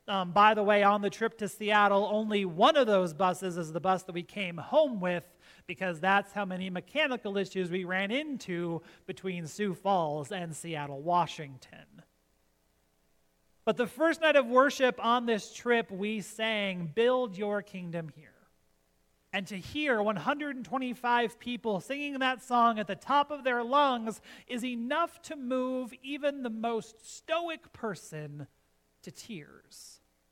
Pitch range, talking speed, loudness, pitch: 175-245 Hz, 150 wpm, -30 LUFS, 205 Hz